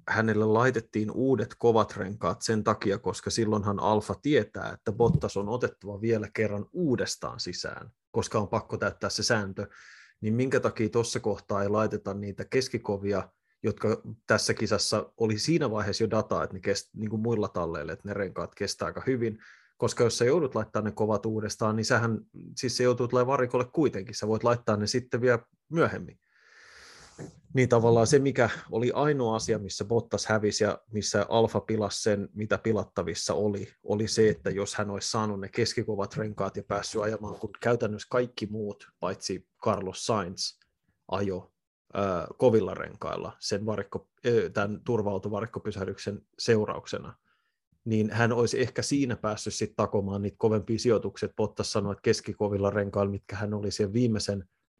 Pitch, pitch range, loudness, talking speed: 110 Hz, 100-115 Hz, -29 LUFS, 160 wpm